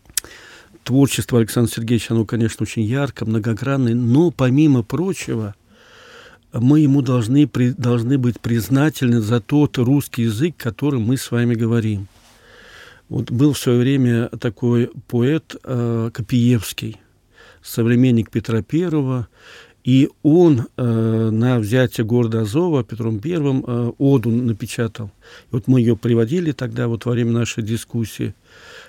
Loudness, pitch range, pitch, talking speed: -18 LUFS, 115-135 Hz, 120 Hz, 130 wpm